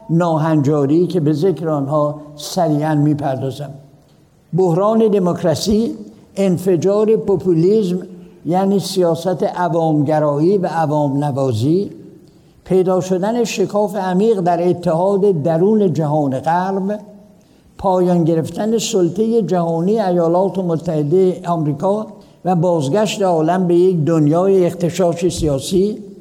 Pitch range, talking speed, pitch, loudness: 160-195 Hz, 95 wpm, 180 Hz, -16 LUFS